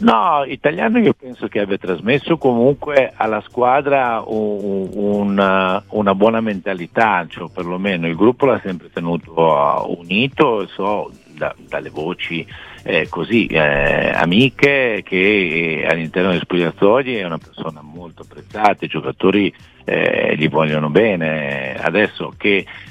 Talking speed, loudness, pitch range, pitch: 125 wpm, -17 LUFS, 80-110 Hz, 95 Hz